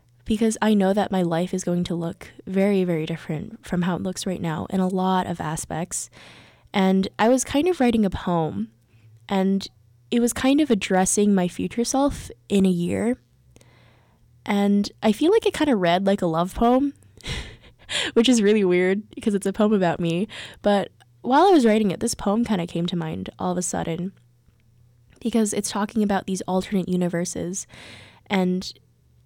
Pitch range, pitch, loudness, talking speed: 175-215 Hz, 190 Hz, -22 LUFS, 185 wpm